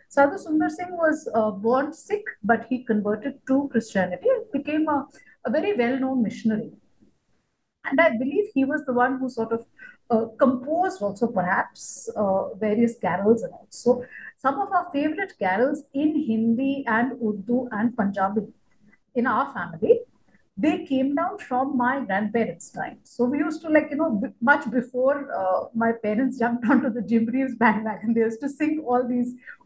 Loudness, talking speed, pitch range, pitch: -24 LUFS, 170 wpm, 225-290 Hz, 250 Hz